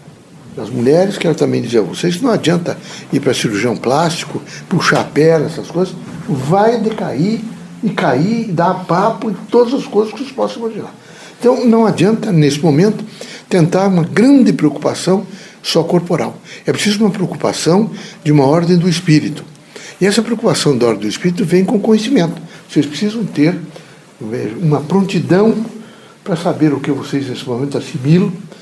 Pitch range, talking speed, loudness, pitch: 155-215 Hz, 160 wpm, -14 LUFS, 180 Hz